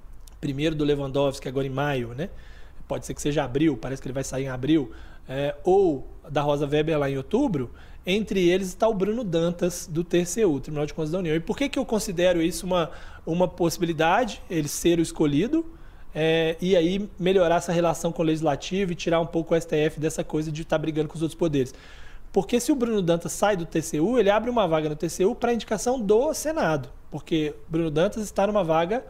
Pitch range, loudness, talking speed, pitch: 150-190 Hz, -25 LUFS, 210 wpm, 165 Hz